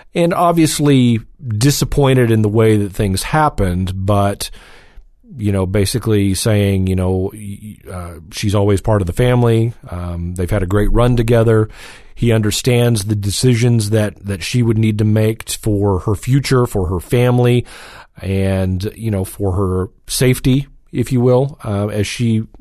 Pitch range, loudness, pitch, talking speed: 100-125 Hz, -15 LUFS, 110 Hz, 155 wpm